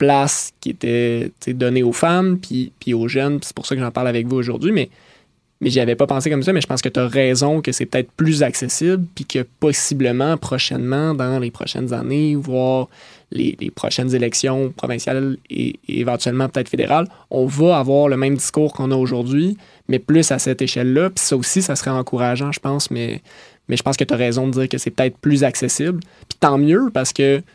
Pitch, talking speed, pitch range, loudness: 130 Hz, 220 wpm, 125-145 Hz, -18 LUFS